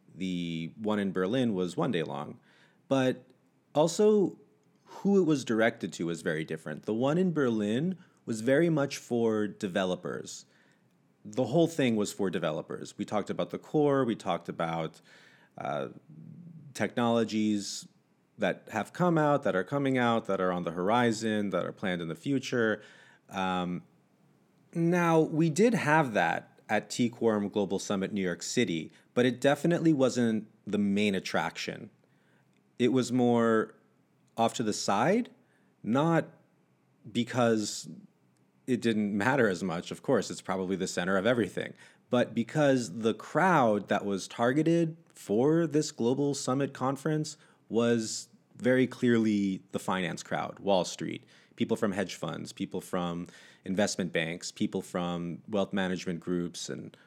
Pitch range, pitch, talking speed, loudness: 95-140 Hz, 115 Hz, 145 wpm, -30 LUFS